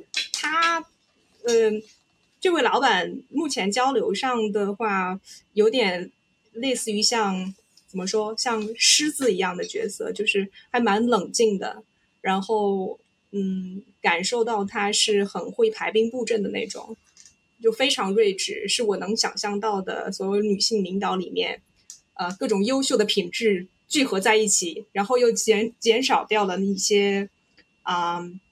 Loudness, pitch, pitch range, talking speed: -23 LUFS, 215 Hz, 200-240 Hz, 210 characters per minute